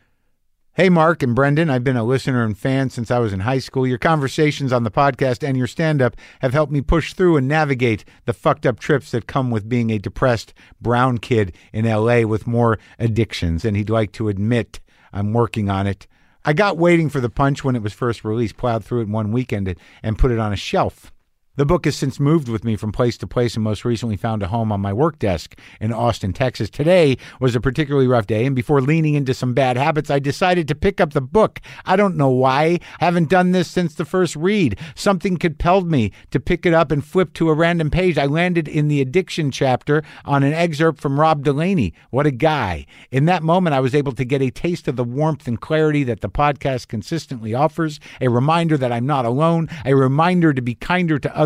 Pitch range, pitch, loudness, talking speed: 115-160 Hz, 135 Hz, -19 LUFS, 230 wpm